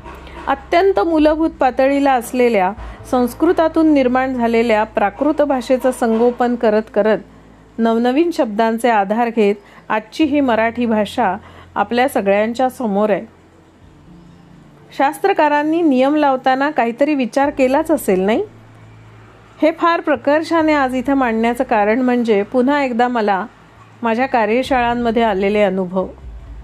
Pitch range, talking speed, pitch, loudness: 215-275 Hz, 105 wpm, 245 Hz, -16 LUFS